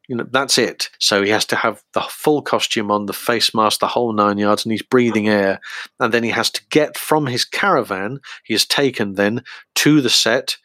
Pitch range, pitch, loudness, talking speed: 105-130 Hz, 115 Hz, -17 LUFS, 225 wpm